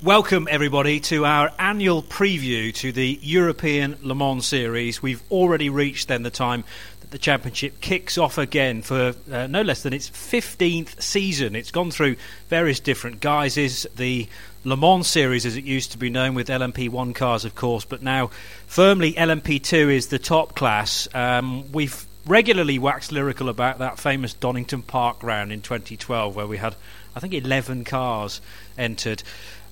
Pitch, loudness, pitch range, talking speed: 130 Hz, -22 LUFS, 120-150 Hz, 165 wpm